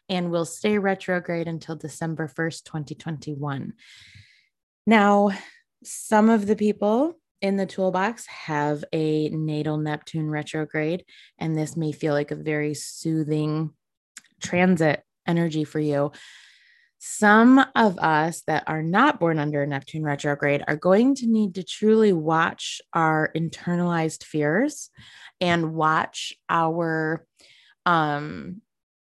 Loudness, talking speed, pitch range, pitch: -23 LUFS, 120 wpm, 155-195 Hz, 165 Hz